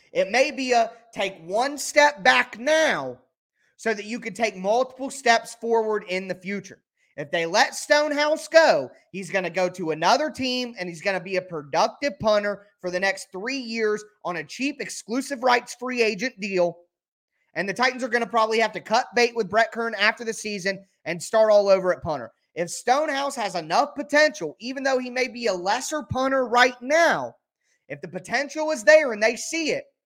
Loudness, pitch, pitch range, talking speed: -23 LUFS, 225 Hz, 190-260 Hz, 200 wpm